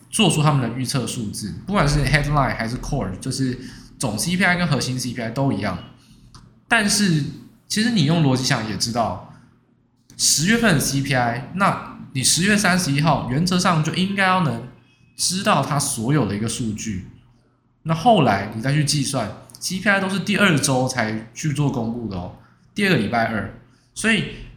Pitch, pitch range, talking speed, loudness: 135 Hz, 120-175 Hz, 285 characters per minute, -20 LUFS